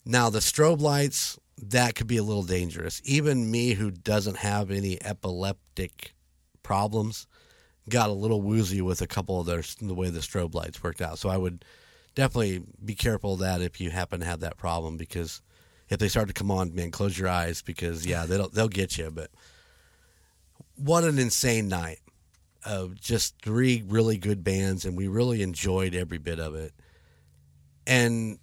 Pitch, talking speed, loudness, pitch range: 95 Hz, 180 wpm, -28 LUFS, 85-110 Hz